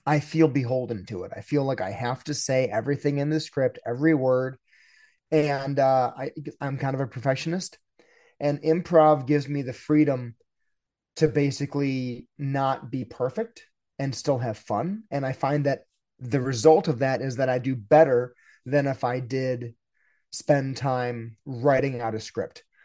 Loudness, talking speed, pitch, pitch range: -25 LUFS, 170 wpm, 135 Hz, 130-150 Hz